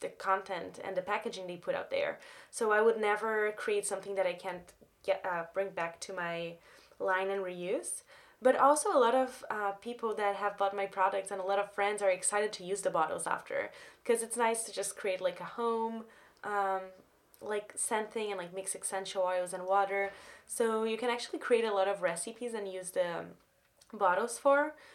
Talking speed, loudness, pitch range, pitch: 205 wpm, -33 LUFS, 190-225 Hz, 200 Hz